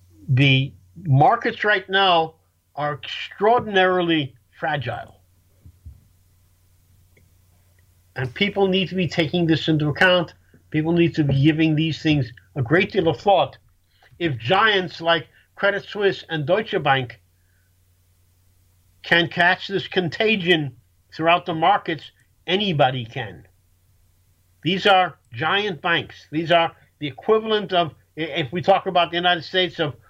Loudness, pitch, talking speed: -20 LUFS, 155 Hz, 125 wpm